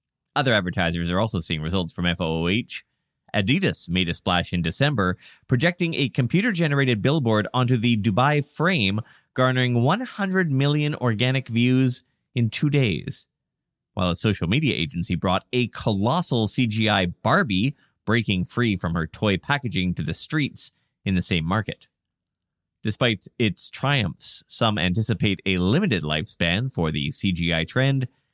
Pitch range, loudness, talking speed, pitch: 90-130 Hz, -23 LUFS, 140 wpm, 110 Hz